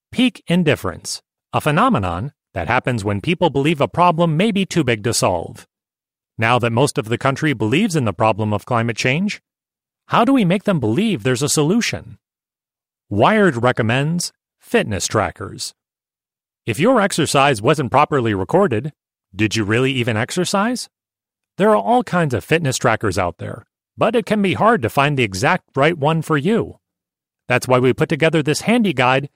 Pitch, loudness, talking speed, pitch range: 140 Hz, -17 LUFS, 170 wpm, 115-175 Hz